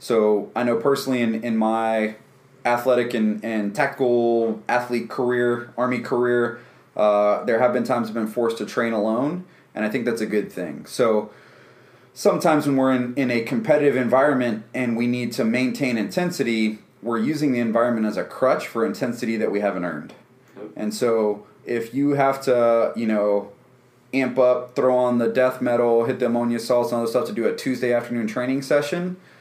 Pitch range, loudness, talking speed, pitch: 115-130 Hz, -22 LUFS, 185 wpm, 120 Hz